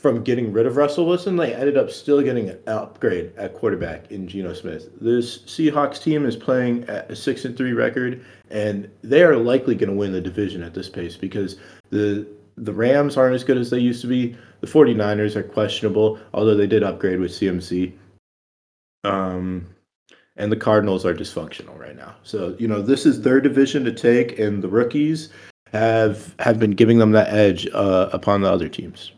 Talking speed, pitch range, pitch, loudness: 195 wpm, 95-125 Hz, 110 Hz, -20 LUFS